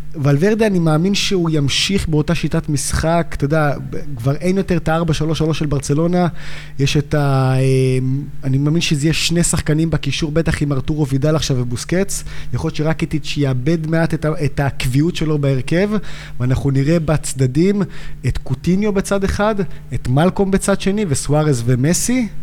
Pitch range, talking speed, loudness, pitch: 140-170 Hz, 155 wpm, -17 LUFS, 155 Hz